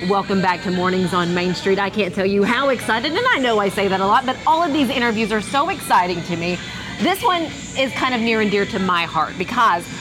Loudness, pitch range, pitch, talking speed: -18 LUFS, 185-265 Hz, 200 Hz, 260 wpm